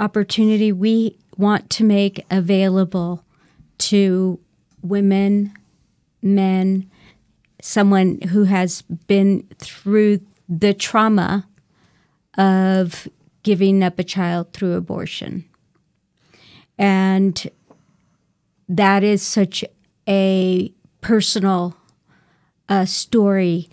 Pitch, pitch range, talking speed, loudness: 195 Hz, 185-205 Hz, 80 wpm, -18 LUFS